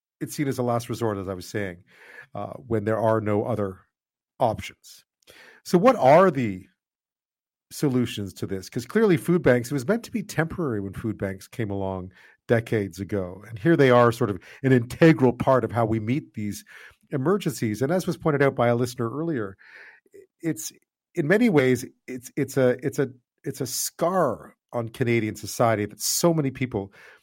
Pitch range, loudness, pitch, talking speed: 105-150 Hz, -24 LUFS, 120 Hz, 180 wpm